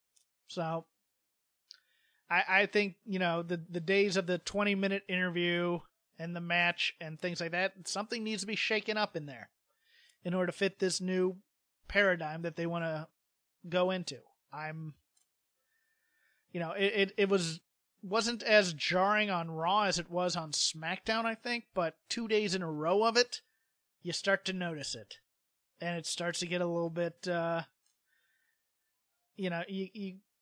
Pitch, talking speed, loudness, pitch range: 185 Hz, 170 wpm, -33 LUFS, 170-210 Hz